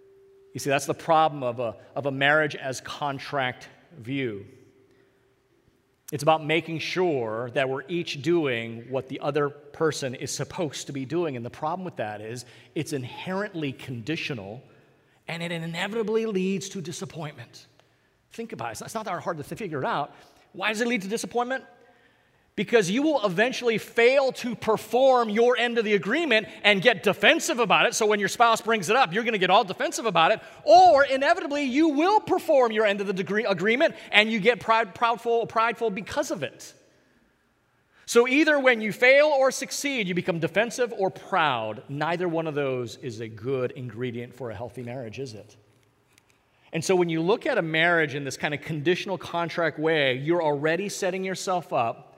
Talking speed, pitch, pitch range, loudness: 185 wpm, 175 Hz, 140-225 Hz, -24 LUFS